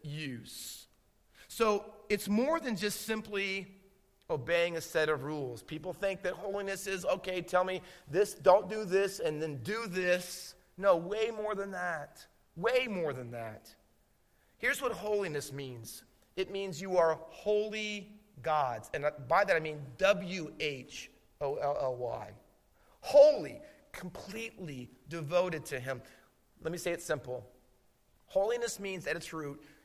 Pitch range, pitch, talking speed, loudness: 150-205 Hz, 180 Hz, 145 wpm, -33 LUFS